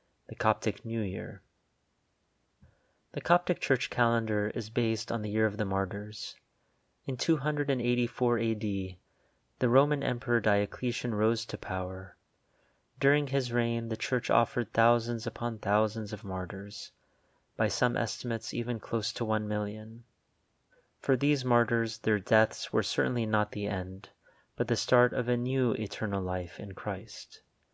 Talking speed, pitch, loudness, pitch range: 140 wpm, 115 Hz, -30 LUFS, 105-120 Hz